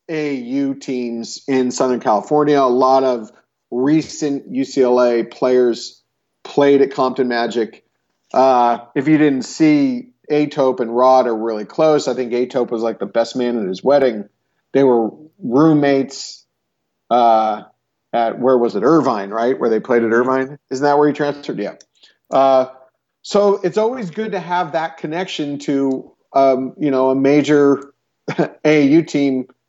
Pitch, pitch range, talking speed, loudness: 135 Hz, 125-150 Hz, 150 wpm, -16 LUFS